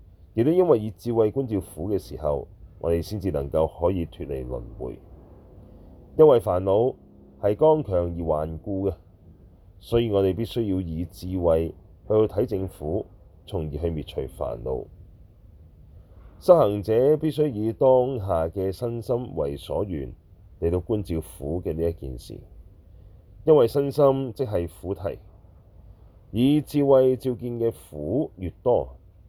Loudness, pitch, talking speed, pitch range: -24 LUFS, 95 Hz, 200 characters per minute, 85-110 Hz